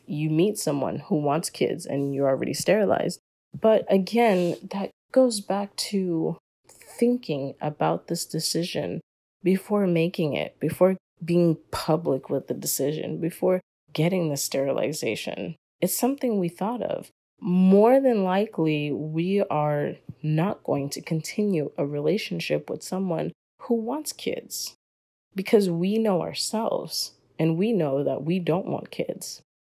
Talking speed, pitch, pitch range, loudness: 135 wpm, 175 Hz, 155-200 Hz, -25 LUFS